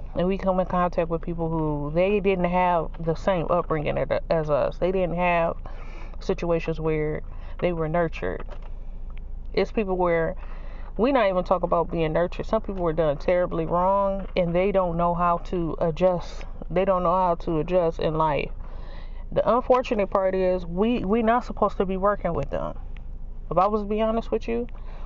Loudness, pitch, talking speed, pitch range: -24 LUFS, 180 Hz, 180 wpm, 165-195 Hz